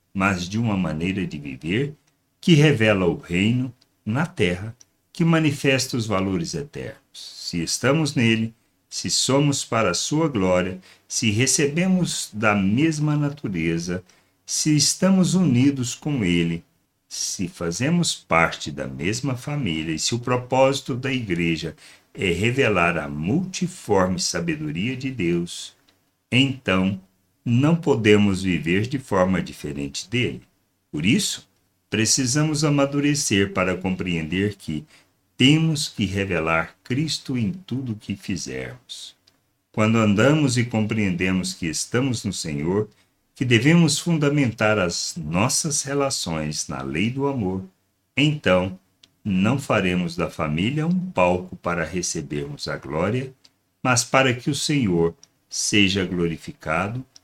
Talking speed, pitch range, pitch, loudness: 120 wpm, 90-140 Hz, 110 Hz, -22 LUFS